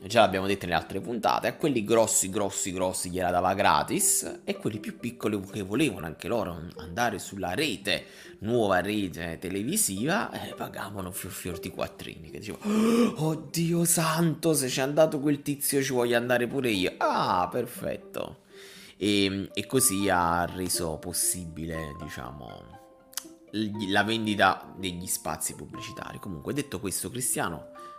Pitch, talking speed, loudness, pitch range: 100 Hz, 140 wpm, -27 LUFS, 90-130 Hz